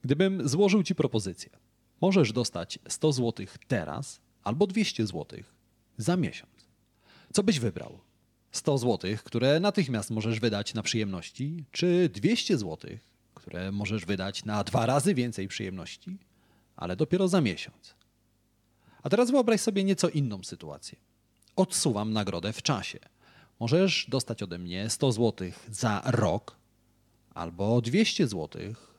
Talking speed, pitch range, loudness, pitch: 130 wpm, 105-160 Hz, -28 LUFS, 120 Hz